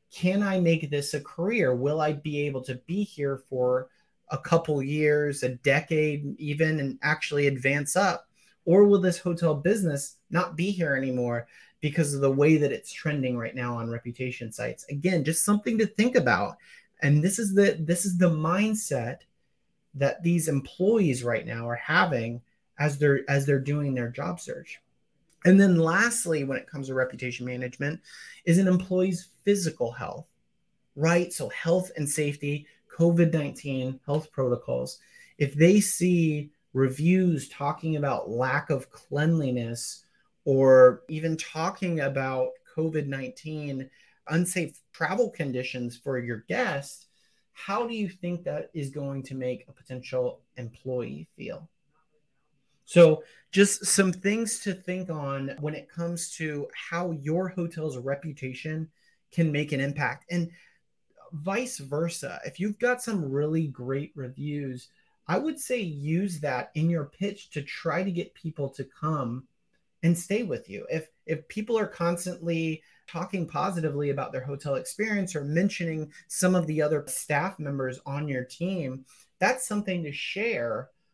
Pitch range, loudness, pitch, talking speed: 140-180 Hz, -27 LUFS, 155 Hz, 150 wpm